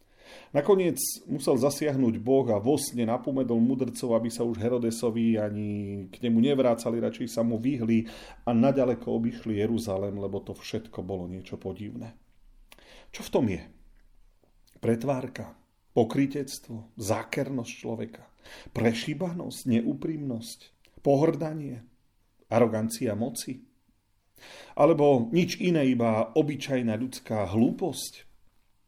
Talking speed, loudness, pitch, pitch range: 105 wpm, -28 LUFS, 115 Hz, 110-130 Hz